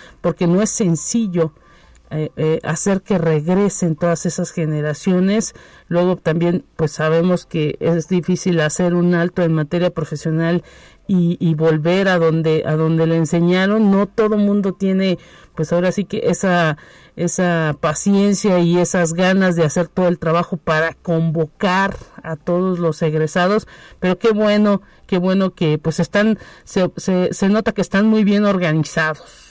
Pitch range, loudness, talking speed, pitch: 165-190 Hz, -17 LUFS, 155 wpm, 175 Hz